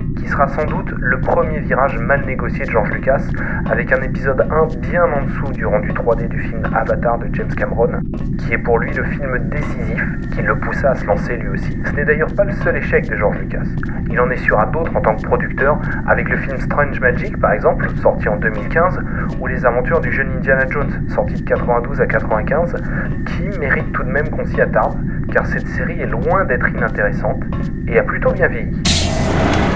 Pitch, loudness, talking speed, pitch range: 145 Hz, -17 LUFS, 210 wpm, 135-165 Hz